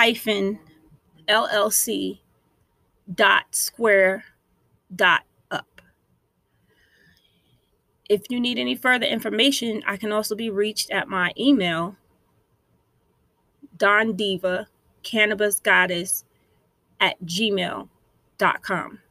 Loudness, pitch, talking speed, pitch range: -22 LUFS, 210 Hz, 80 wpm, 185-220 Hz